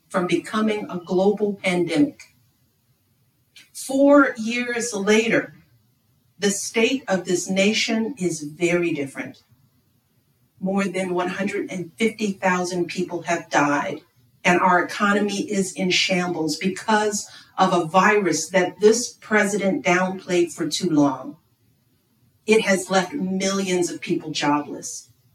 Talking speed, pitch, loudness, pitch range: 110 wpm, 180 Hz, -21 LUFS, 145-205 Hz